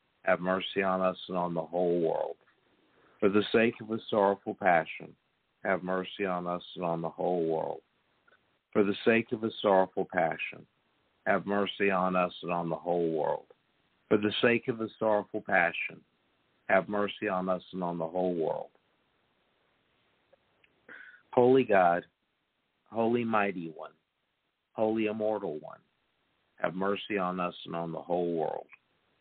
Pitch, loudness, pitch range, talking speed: 95 Hz, -30 LUFS, 90-105 Hz, 150 wpm